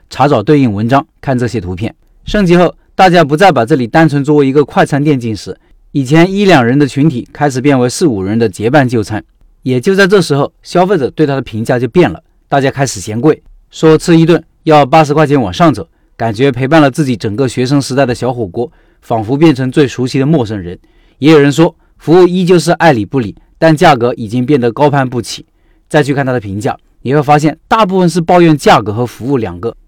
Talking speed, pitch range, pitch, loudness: 325 characters per minute, 120-160 Hz, 140 Hz, -10 LUFS